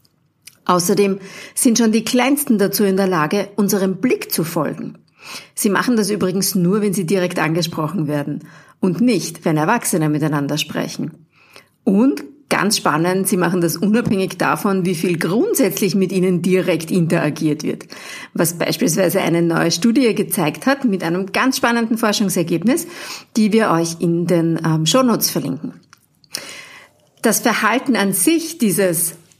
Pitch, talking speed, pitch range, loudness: 190 Hz, 140 wpm, 170-225 Hz, -17 LUFS